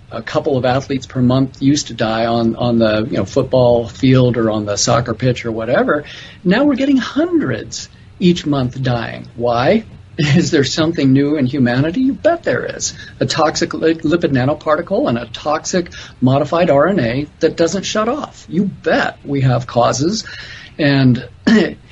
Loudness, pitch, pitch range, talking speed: -15 LUFS, 135 Hz, 120-165 Hz, 165 wpm